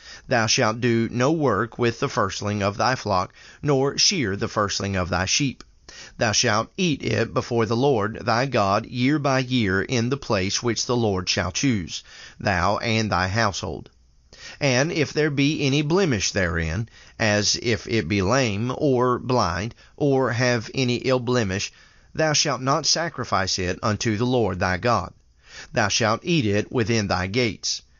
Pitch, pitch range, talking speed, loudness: 115 Hz, 100-130 Hz, 165 wpm, -22 LUFS